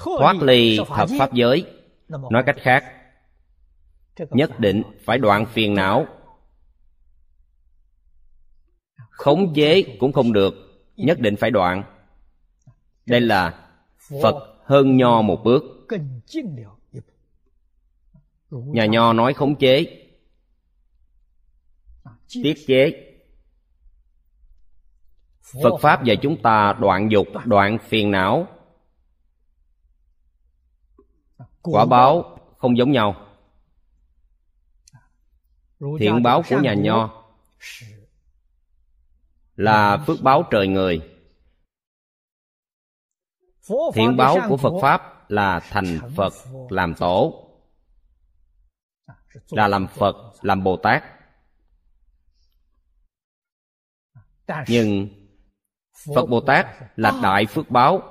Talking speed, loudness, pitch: 90 wpm, -18 LUFS, 90 Hz